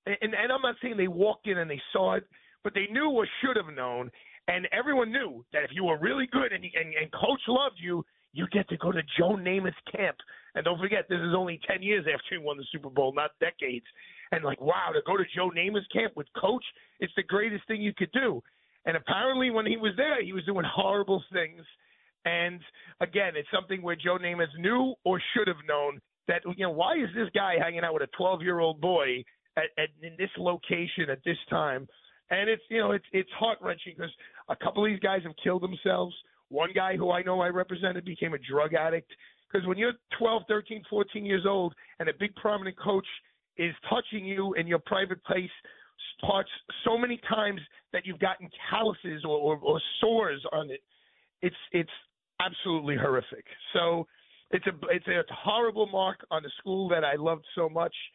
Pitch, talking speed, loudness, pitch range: 185 Hz, 210 wpm, -29 LUFS, 170-210 Hz